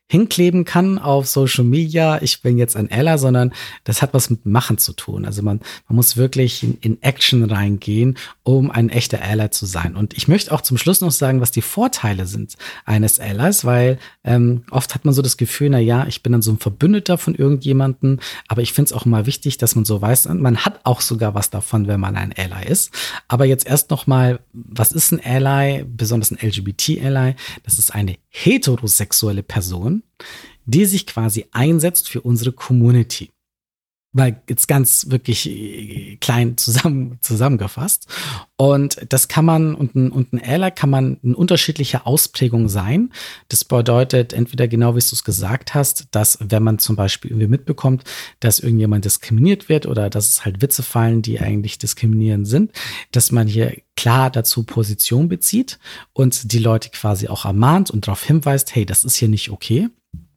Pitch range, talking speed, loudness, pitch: 110-140 Hz, 185 wpm, -16 LUFS, 125 Hz